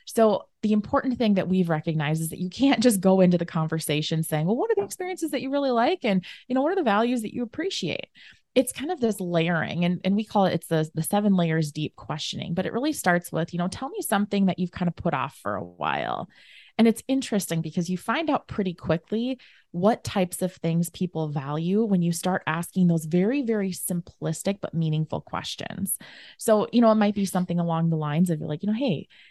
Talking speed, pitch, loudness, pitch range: 235 wpm, 190 Hz, -25 LUFS, 170-225 Hz